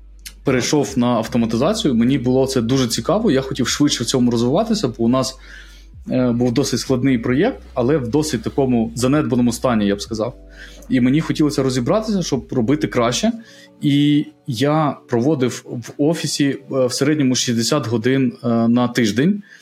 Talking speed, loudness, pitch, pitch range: 145 wpm, -18 LUFS, 130 Hz, 120-145 Hz